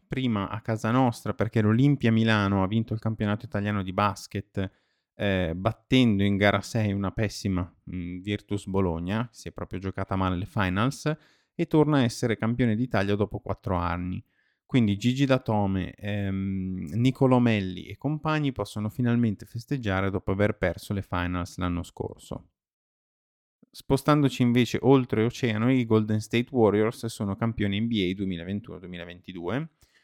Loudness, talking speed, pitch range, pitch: -26 LUFS, 140 wpm, 95-120 Hz, 105 Hz